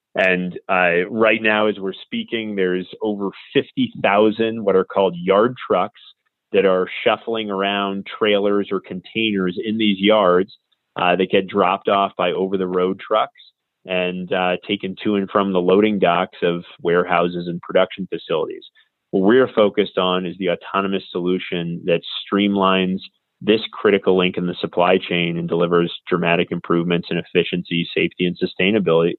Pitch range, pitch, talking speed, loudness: 90-105 Hz, 95 Hz, 155 wpm, -19 LUFS